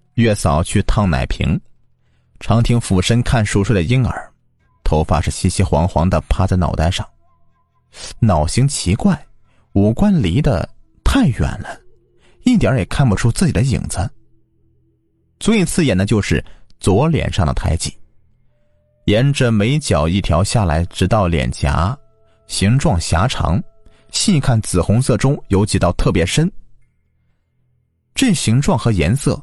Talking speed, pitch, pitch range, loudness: 200 characters per minute, 105 Hz, 90-125 Hz, -16 LUFS